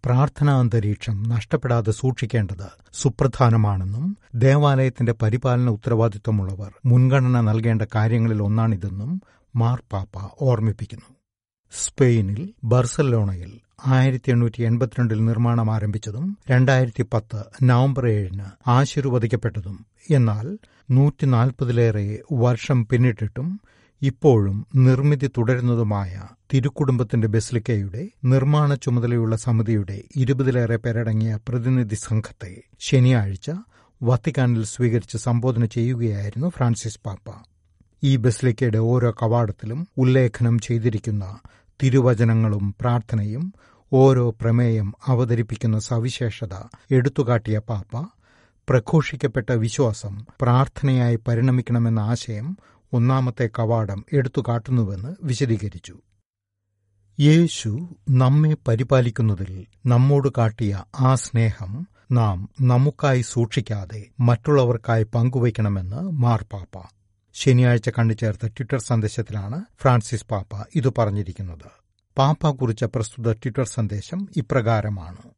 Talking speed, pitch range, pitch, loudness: 80 wpm, 110-130 Hz, 120 Hz, -21 LUFS